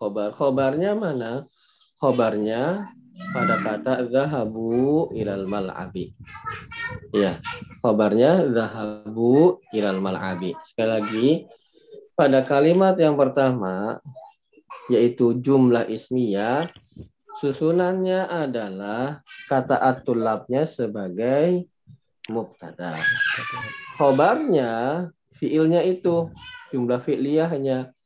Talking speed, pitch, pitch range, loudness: 75 wpm, 135 Hz, 115-175 Hz, -22 LUFS